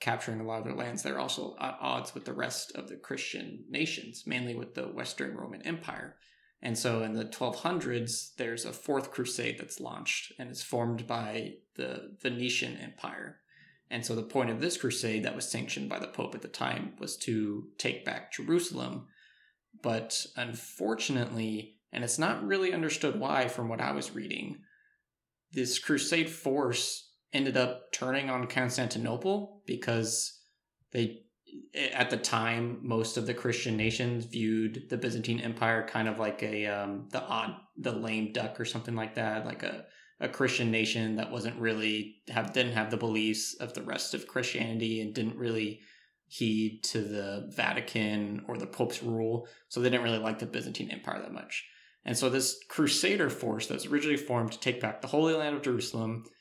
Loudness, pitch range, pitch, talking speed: -33 LUFS, 110-125 Hz, 115 Hz, 180 wpm